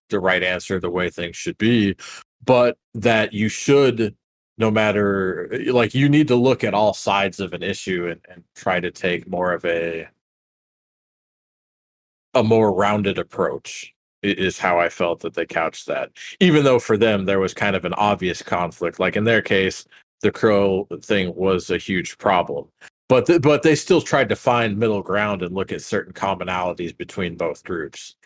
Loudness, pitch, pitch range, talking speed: -20 LUFS, 100 Hz, 95-115 Hz, 180 wpm